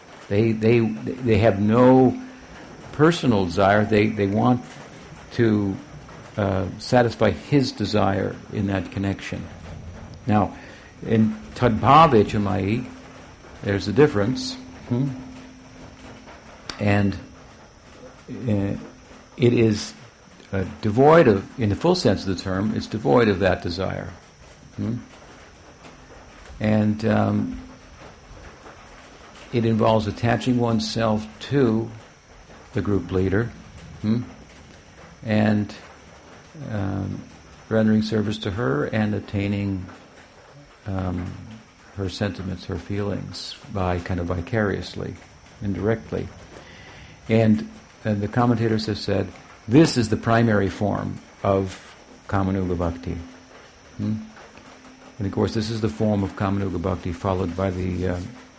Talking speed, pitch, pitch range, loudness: 105 wpm, 105 Hz, 95-115 Hz, -22 LUFS